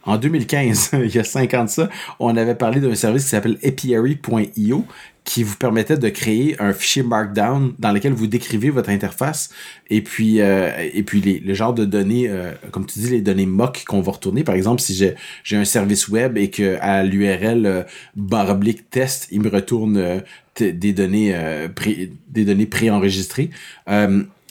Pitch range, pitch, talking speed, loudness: 100-120 Hz, 110 Hz, 190 wpm, -18 LUFS